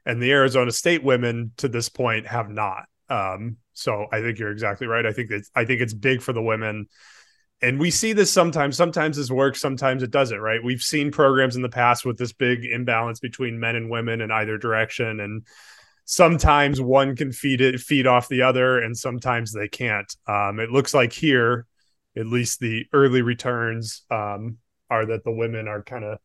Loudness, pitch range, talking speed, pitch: -22 LUFS, 110-130 Hz, 200 wpm, 120 Hz